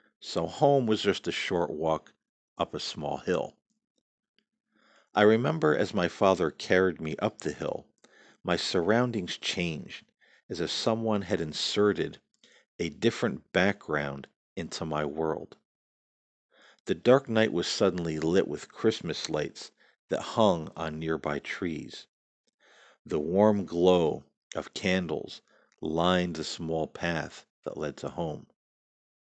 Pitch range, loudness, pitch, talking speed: 80-110 Hz, -29 LUFS, 95 Hz, 125 wpm